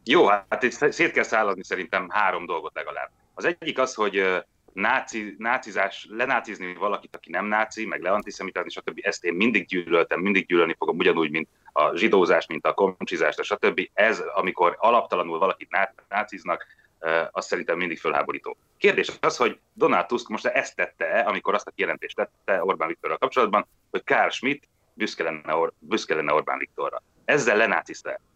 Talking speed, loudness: 155 wpm, -24 LUFS